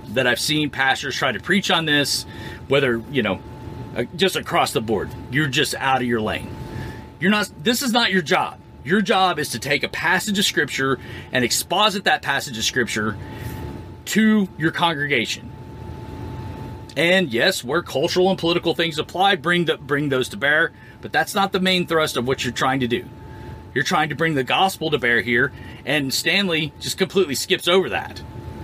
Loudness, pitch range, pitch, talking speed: -20 LUFS, 125-185 Hz, 145 Hz, 185 wpm